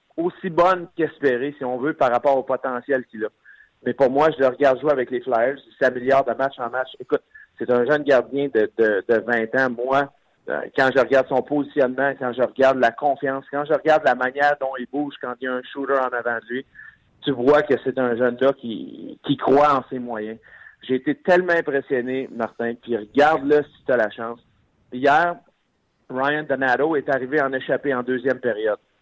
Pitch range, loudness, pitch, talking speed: 125-145 Hz, -21 LUFS, 135 Hz, 210 wpm